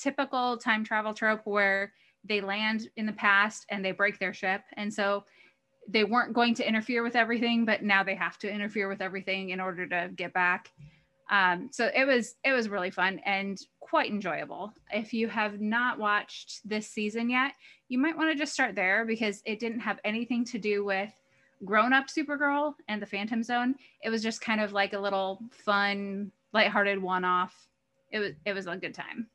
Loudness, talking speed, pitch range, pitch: -29 LUFS, 200 wpm, 195-235 Hz, 215 Hz